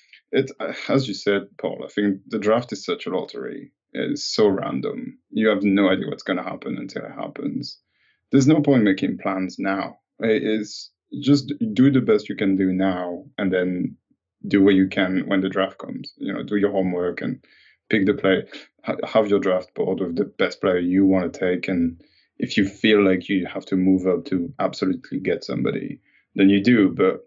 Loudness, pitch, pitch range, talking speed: -22 LUFS, 100 Hz, 95-110 Hz, 205 wpm